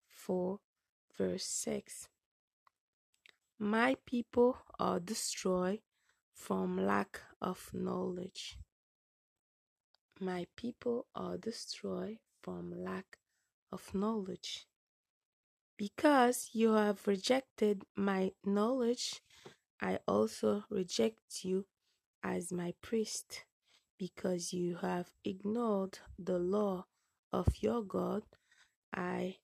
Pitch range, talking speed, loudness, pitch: 180-225 Hz, 85 wpm, -37 LUFS, 200 Hz